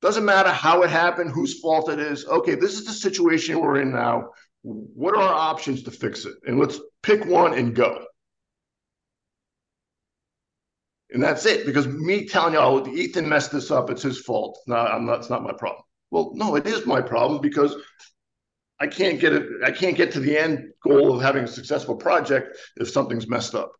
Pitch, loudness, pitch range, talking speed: 160 Hz, -22 LUFS, 145-190 Hz, 200 wpm